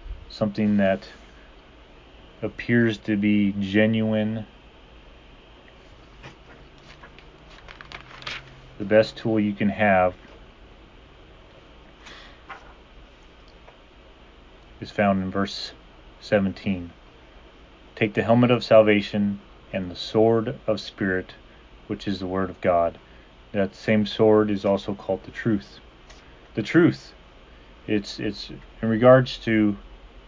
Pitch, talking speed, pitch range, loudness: 100 Hz, 95 wpm, 80-110 Hz, -23 LUFS